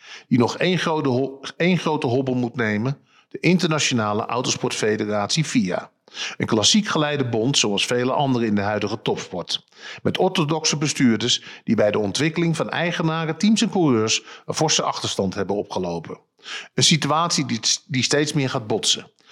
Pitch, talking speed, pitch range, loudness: 140 Hz, 150 wpm, 120-165 Hz, -21 LUFS